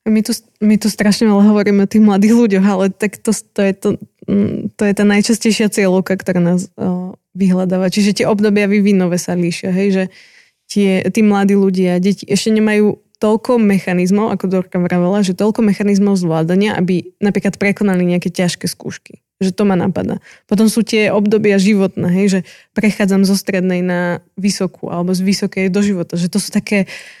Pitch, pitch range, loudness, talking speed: 200 Hz, 185-210 Hz, -14 LUFS, 180 wpm